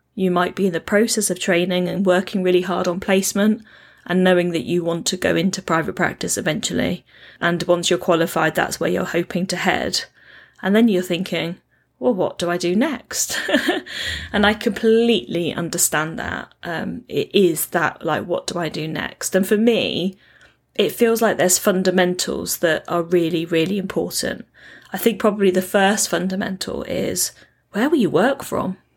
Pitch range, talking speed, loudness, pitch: 175-205 Hz, 175 wpm, -20 LUFS, 185 Hz